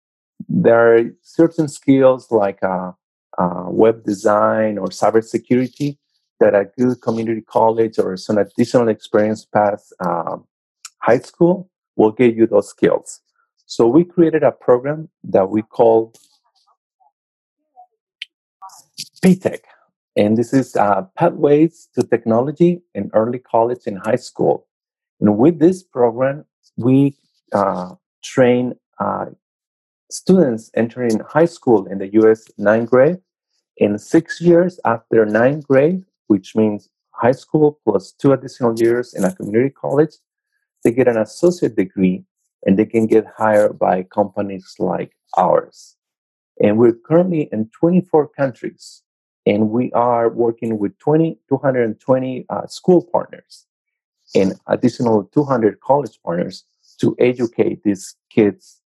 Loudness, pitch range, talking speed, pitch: -17 LUFS, 110-165 Hz, 125 wpm, 120 Hz